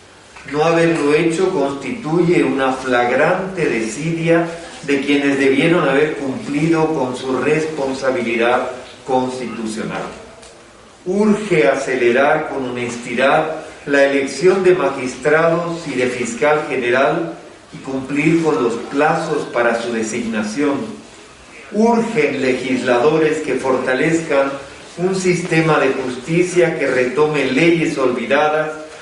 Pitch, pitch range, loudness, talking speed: 140 Hz, 130-160 Hz, -17 LUFS, 100 wpm